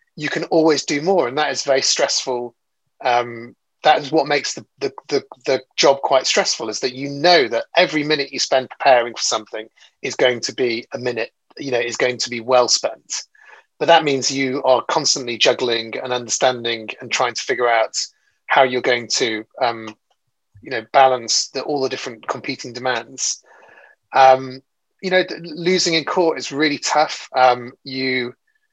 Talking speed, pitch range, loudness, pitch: 180 wpm, 125-155 Hz, -18 LUFS, 135 Hz